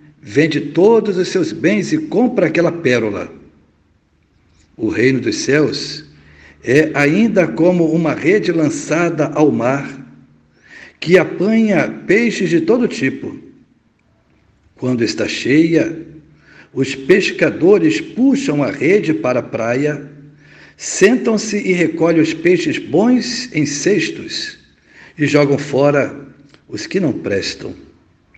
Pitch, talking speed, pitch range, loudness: 155 Hz, 110 wpm, 140-195 Hz, -15 LUFS